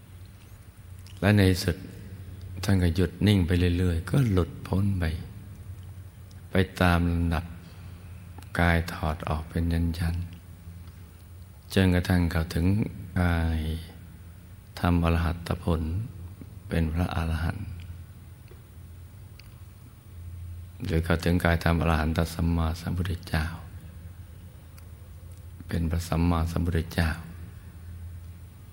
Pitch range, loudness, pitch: 85-95 Hz, -27 LUFS, 90 Hz